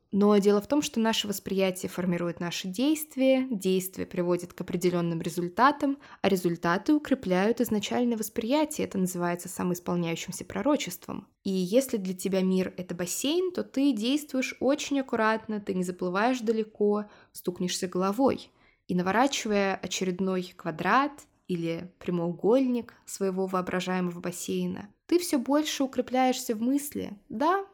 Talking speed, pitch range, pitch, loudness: 125 wpm, 180-255 Hz, 200 Hz, -28 LUFS